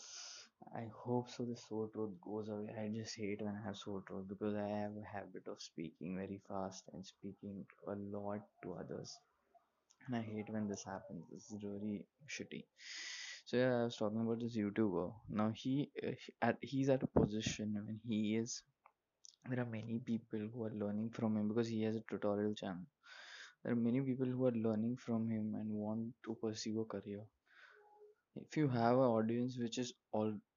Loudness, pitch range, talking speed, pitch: -41 LUFS, 105-120 Hz, 200 wpm, 110 Hz